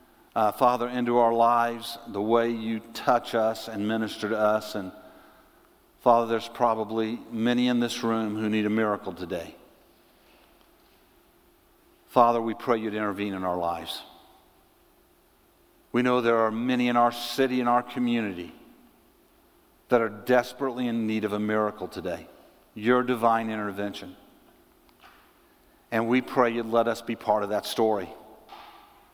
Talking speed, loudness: 140 wpm, -26 LUFS